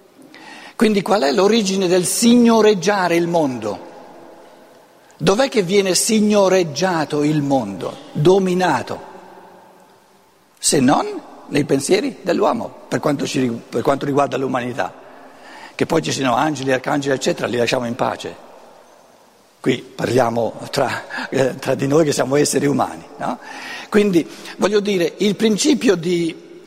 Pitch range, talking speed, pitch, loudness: 145-210 Hz, 125 wpm, 185 Hz, -18 LUFS